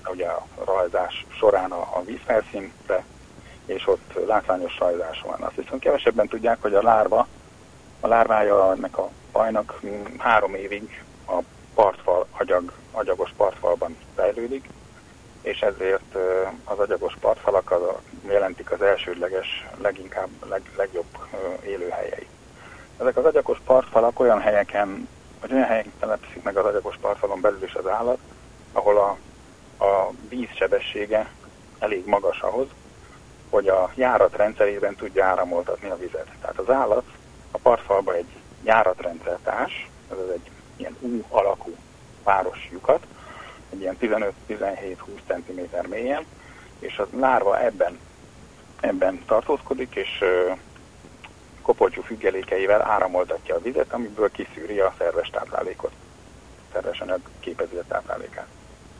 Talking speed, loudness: 115 wpm, -24 LUFS